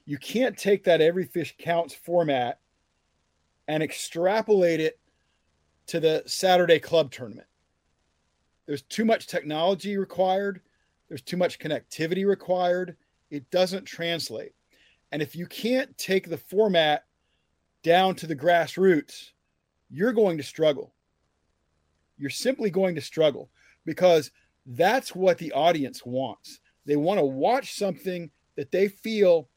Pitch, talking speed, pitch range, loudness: 165 Hz, 130 wpm, 130-190 Hz, -25 LUFS